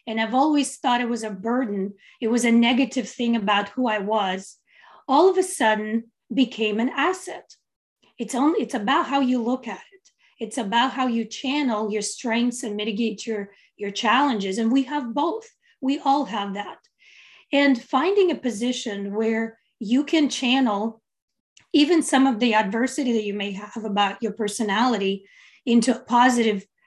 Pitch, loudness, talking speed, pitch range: 240 Hz, -23 LUFS, 170 wpm, 220-275 Hz